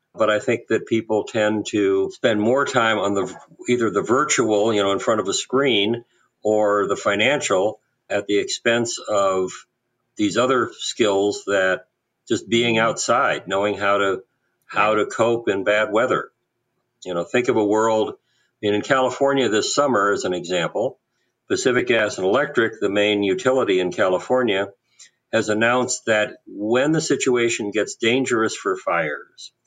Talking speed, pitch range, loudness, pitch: 160 wpm, 100-120 Hz, -20 LUFS, 110 Hz